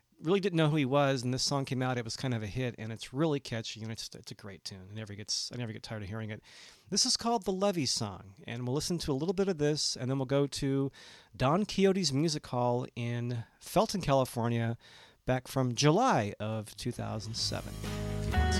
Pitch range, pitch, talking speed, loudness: 110-145 Hz, 125 Hz, 235 wpm, -32 LUFS